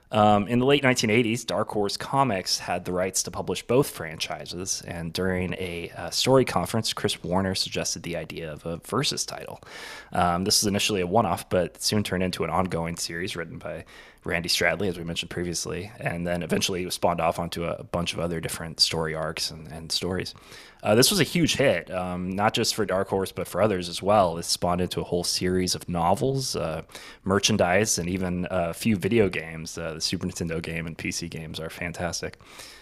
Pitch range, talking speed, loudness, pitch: 85-105 Hz, 210 wpm, -25 LUFS, 90 Hz